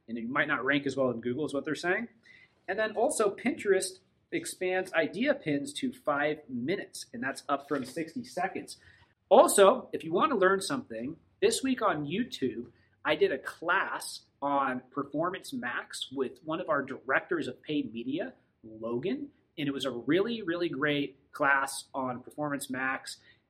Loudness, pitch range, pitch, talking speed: -30 LUFS, 135-215 Hz, 150 Hz, 170 wpm